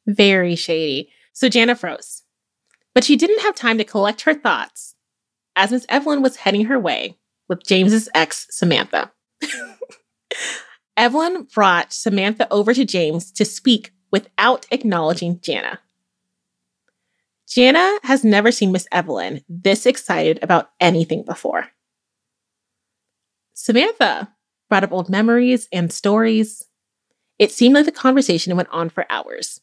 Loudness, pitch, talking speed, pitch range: -17 LUFS, 215 Hz, 130 wpm, 185-255 Hz